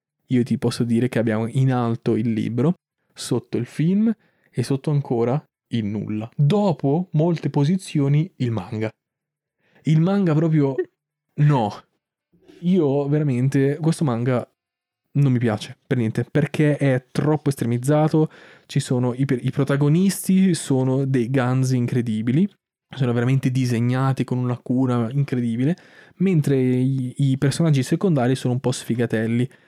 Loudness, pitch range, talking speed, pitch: -21 LUFS, 125-155 Hz, 130 wpm, 135 Hz